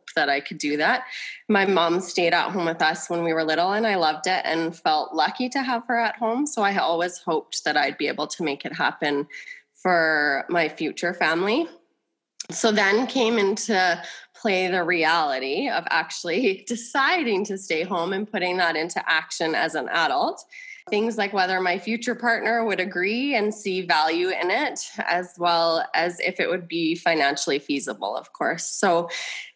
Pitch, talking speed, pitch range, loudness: 185 Hz, 185 wpm, 170-230 Hz, -23 LUFS